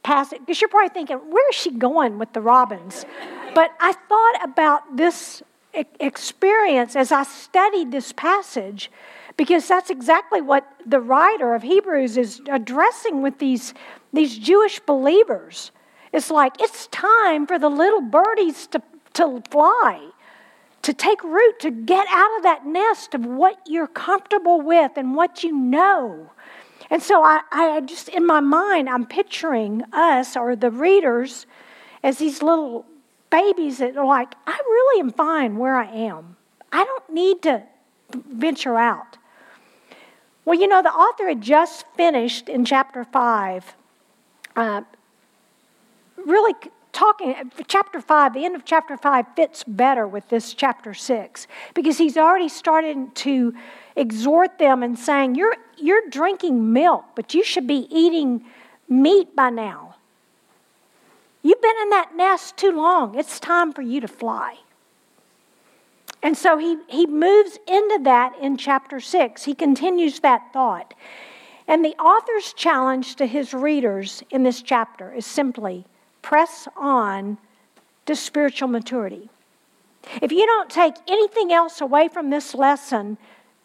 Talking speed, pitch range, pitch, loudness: 145 wpm, 255-350 Hz, 300 Hz, -19 LUFS